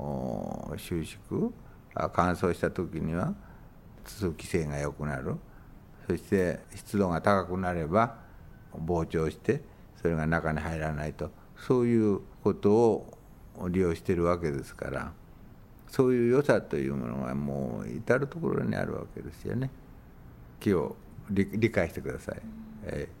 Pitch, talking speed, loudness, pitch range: 85 Hz, 260 characters per minute, -30 LUFS, 75-100 Hz